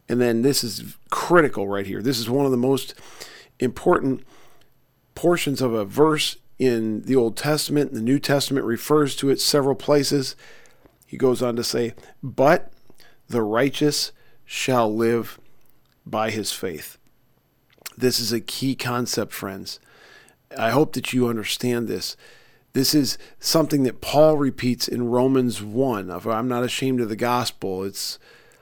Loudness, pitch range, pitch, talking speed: -22 LUFS, 115-140 Hz, 125 Hz, 150 wpm